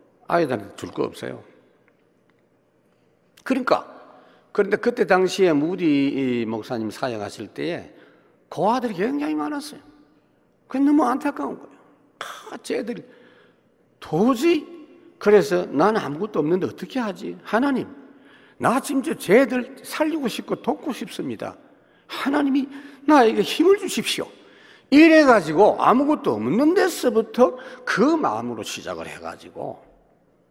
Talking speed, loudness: 270 characters per minute, -21 LUFS